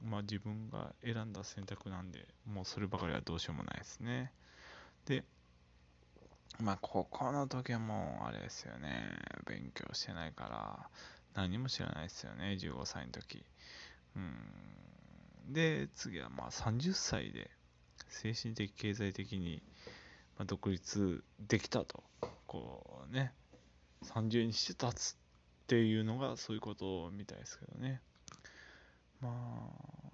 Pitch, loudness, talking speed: 100 Hz, -41 LUFS, 235 characters per minute